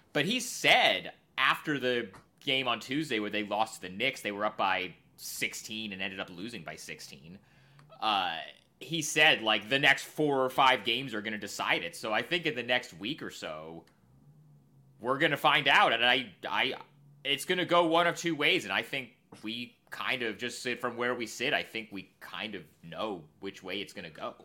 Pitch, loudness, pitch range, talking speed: 125 Hz, -29 LUFS, 110-150 Hz, 220 wpm